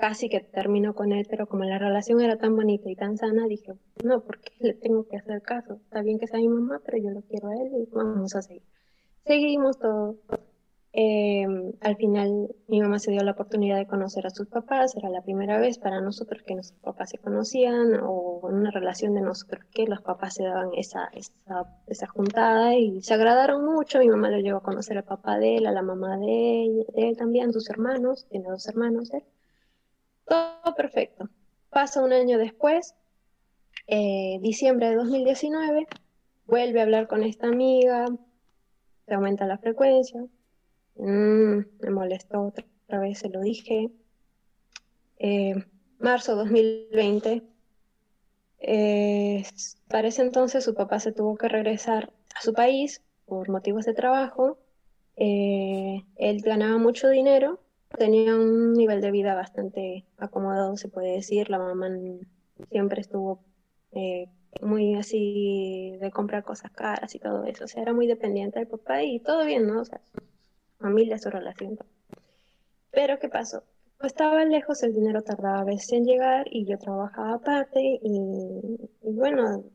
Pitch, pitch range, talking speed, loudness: 215 Hz, 200-235 Hz, 170 wpm, -25 LUFS